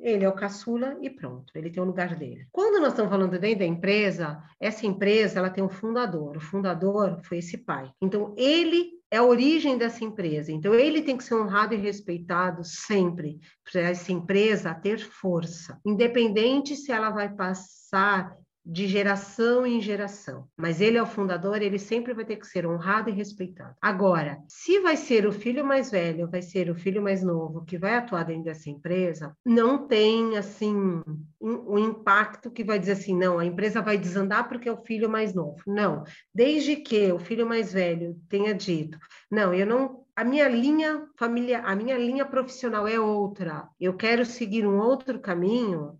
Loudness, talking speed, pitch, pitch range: -26 LUFS, 185 wpm, 205 Hz, 180-230 Hz